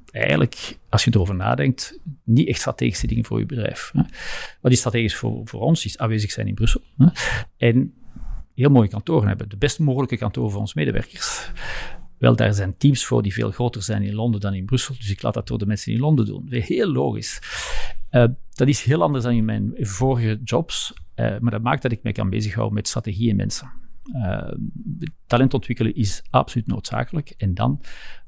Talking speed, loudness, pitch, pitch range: 195 wpm, -22 LUFS, 115 Hz, 105-125 Hz